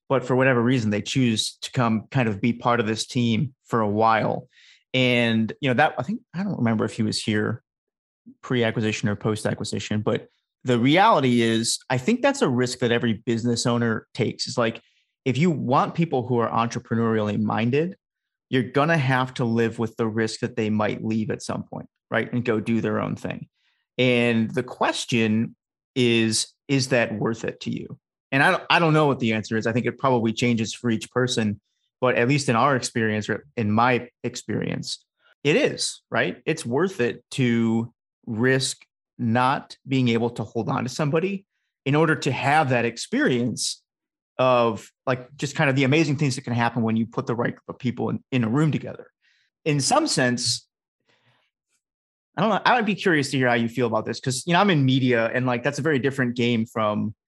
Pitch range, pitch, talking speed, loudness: 115-135 Hz, 120 Hz, 205 wpm, -23 LUFS